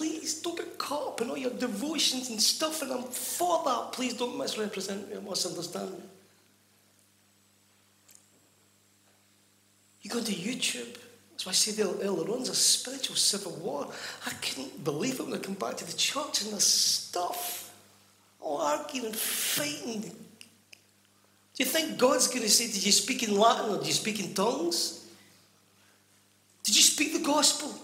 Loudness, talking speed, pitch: -28 LUFS, 170 wpm, 210 Hz